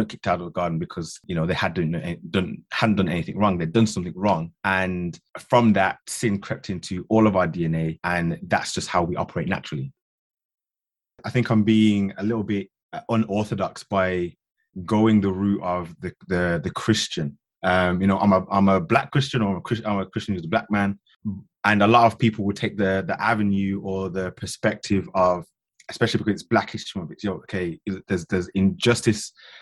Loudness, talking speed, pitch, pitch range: -23 LUFS, 210 wpm, 100 Hz, 95-110 Hz